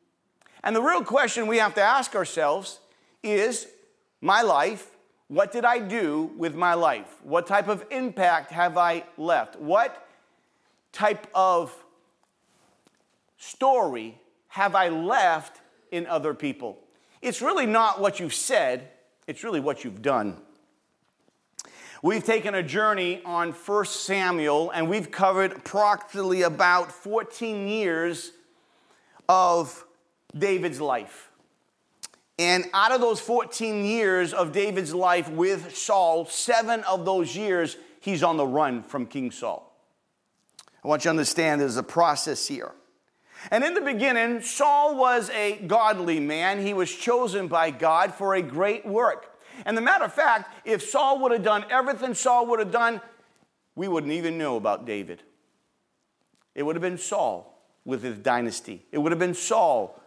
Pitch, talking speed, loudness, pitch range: 190 Hz, 145 wpm, -24 LUFS, 165-225 Hz